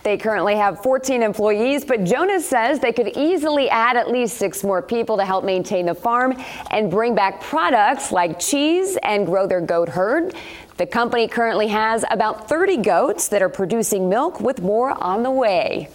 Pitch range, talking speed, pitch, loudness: 195-260 Hz, 185 wpm, 225 Hz, -19 LUFS